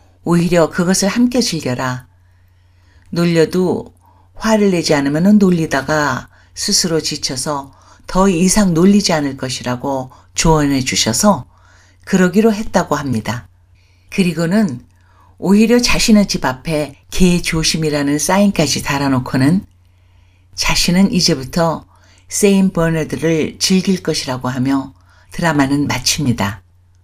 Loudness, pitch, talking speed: -15 LUFS, 150 Hz, 255 characters per minute